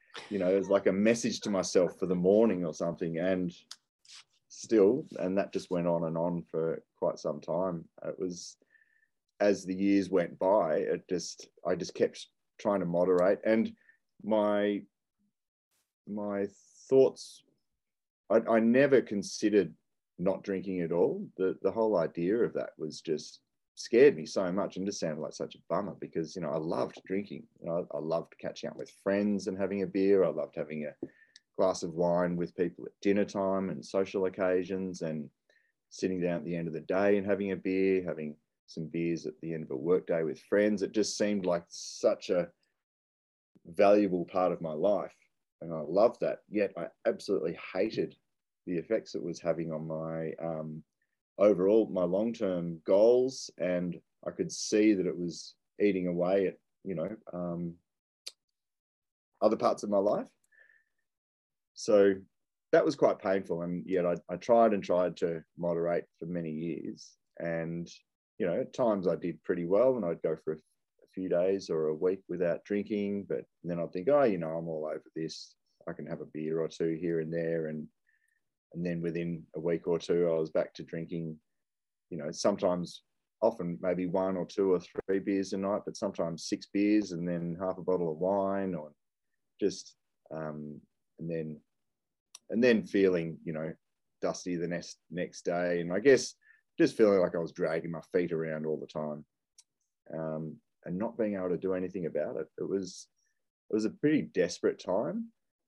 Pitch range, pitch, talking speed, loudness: 85-100 Hz, 90 Hz, 185 wpm, -31 LUFS